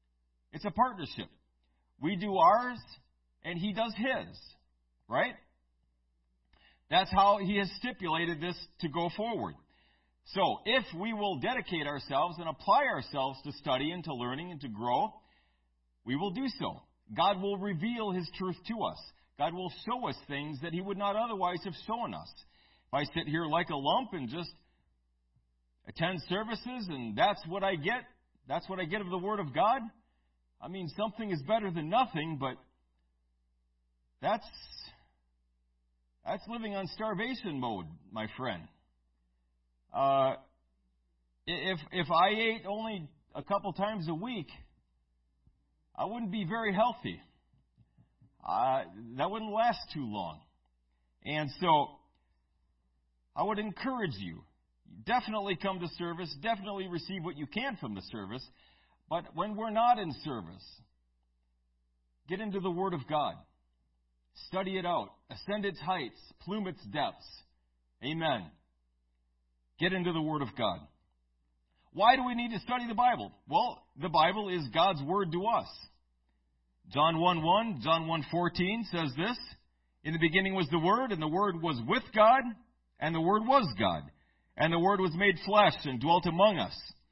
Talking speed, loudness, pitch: 150 wpm, -32 LUFS, 165 Hz